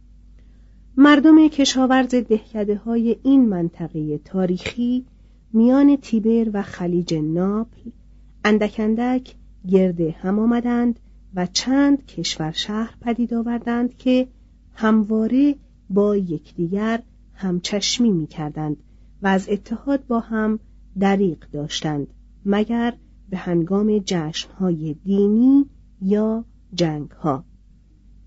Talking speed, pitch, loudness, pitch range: 95 wpm, 215 Hz, -20 LUFS, 180-235 Hz